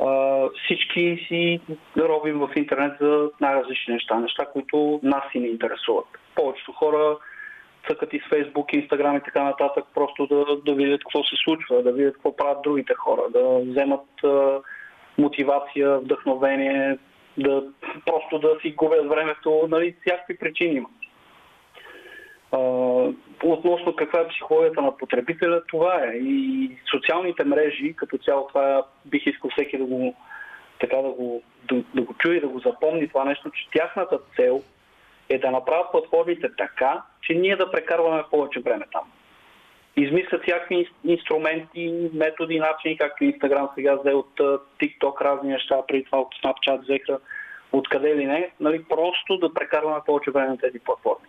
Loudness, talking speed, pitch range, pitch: -23 LUFS, 150 wpm, 140-175 Hz, 150 Hz